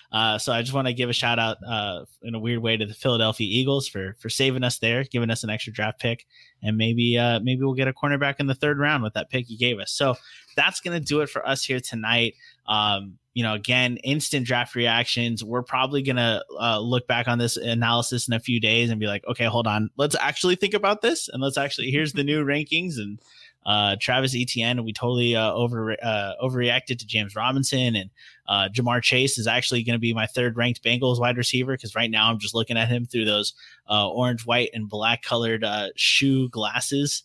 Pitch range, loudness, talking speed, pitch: 110-130 Hz, -23 LUFS, 230 wpm, 120 Hz